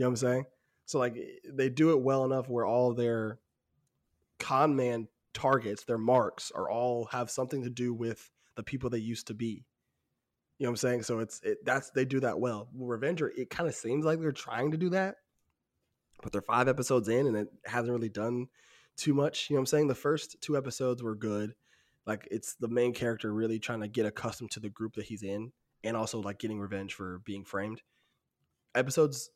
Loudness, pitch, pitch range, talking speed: -32 LUFS, 120 Hz, 110-130 Hz, 215 wpm